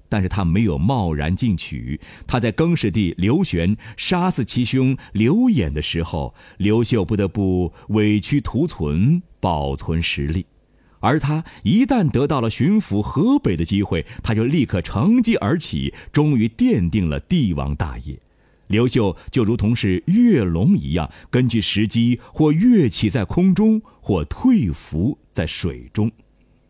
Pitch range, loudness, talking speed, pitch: 90-145 Hz, -19 LUFS, 215 characters per minute, 110 Hz